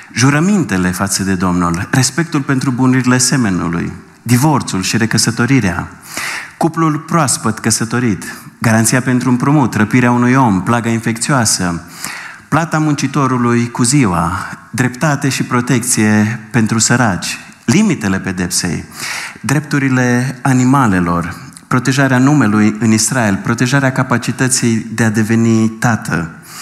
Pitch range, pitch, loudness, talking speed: 110-135 Hz, 120 Hz, -13 LUFS, 100 wpm